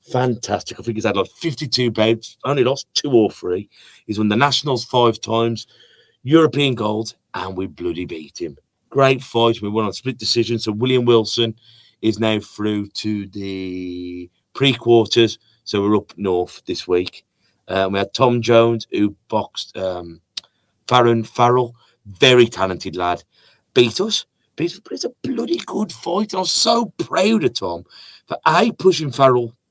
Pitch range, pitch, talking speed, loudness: 105-125 Hz, 115 Hz, 160 wpm, -18 LUFS